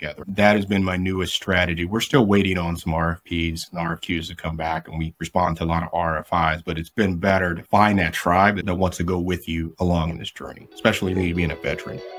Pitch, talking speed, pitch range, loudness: 85 Hz, 235 wpm, 80-95 Hz, -22 LUFS